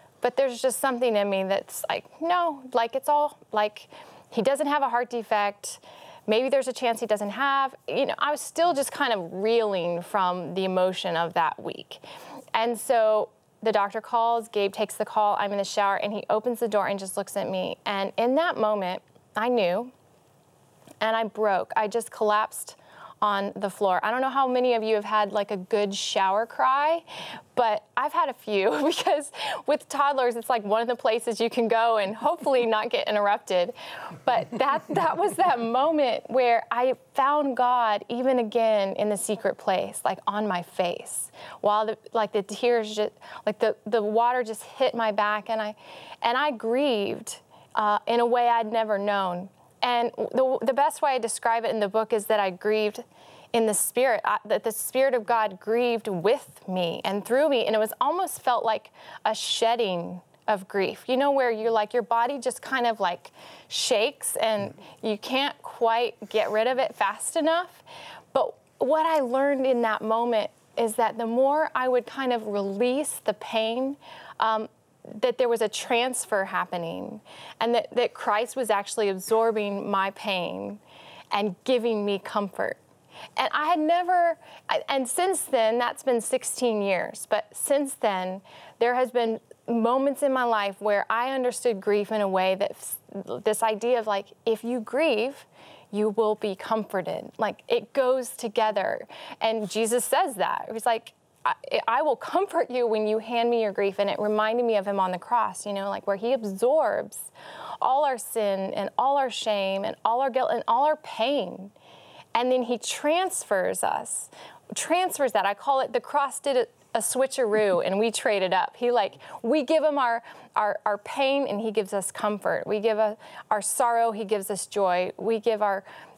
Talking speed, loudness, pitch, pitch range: 190 wpm, -26 LUFS, 230 Hz, 210-260 Hz